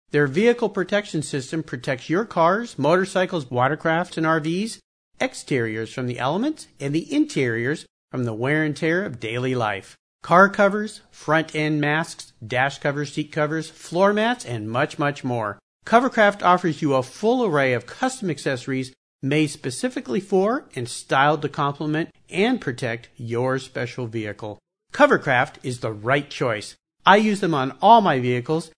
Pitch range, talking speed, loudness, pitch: 130-185 Hz, 155 wpm, -22 LUFS, 155 Hz